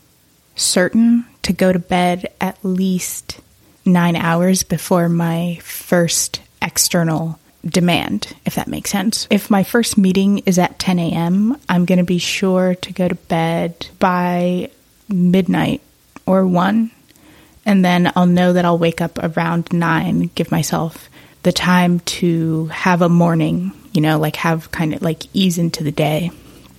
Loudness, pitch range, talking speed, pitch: -16 LUFS, 165-185 Hz, 150 wpm, 180 Hz